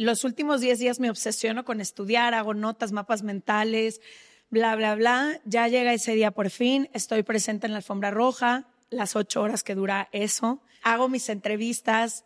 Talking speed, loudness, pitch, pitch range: 175 wpm, -25 LUFS, 225 Hz, 215-245 Hz